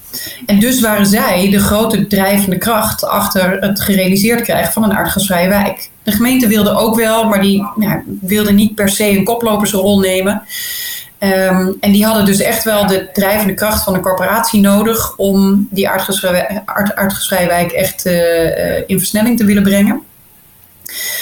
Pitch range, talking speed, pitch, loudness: 190-215 Hz, 165 wpm, 205 Hz, -12 LUFS